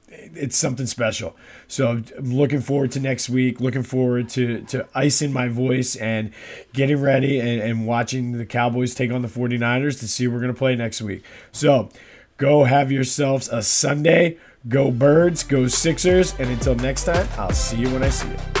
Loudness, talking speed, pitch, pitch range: -20 LUFS, 185 wpm, 130 Hz, 120-140 Hz